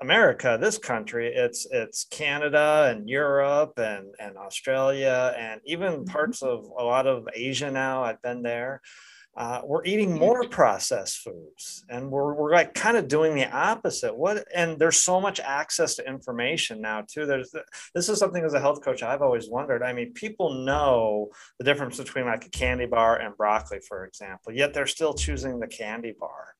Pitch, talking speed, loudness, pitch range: 145 Hz, 185 wpm, -25 LUFS, 125-175 Hz